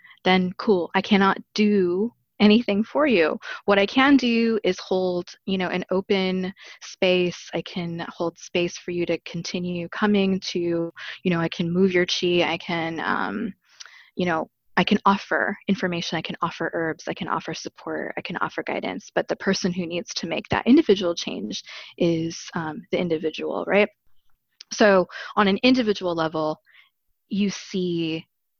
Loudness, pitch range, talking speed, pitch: -23 LUFS, 175-205 Hz, 165 wpm, 185 Hz